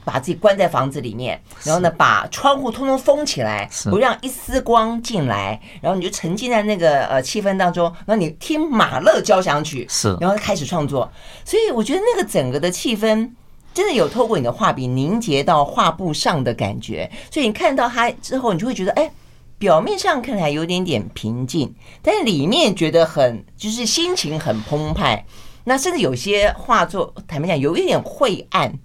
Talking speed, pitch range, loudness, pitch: 295 characters per minute, 150-235 Hz, -18 LUFS, 190 Hz